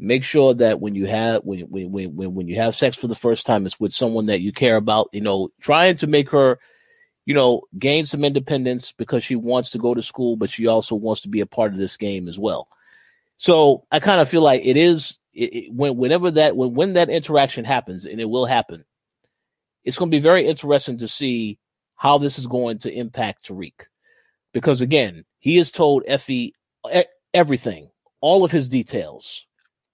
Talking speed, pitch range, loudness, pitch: 205 wpm, 110-150 Hz, -19 LUFS, 125 Hz